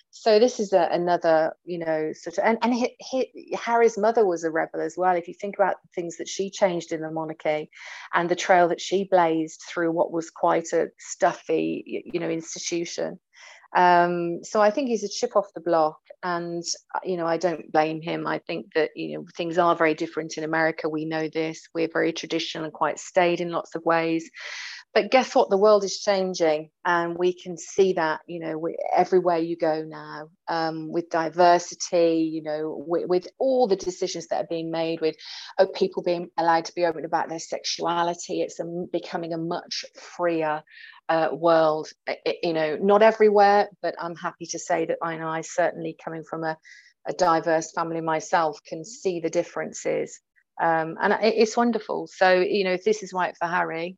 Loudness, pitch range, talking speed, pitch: -24 LUFS, 160-185 Hz, 200 wpm, 170 Hz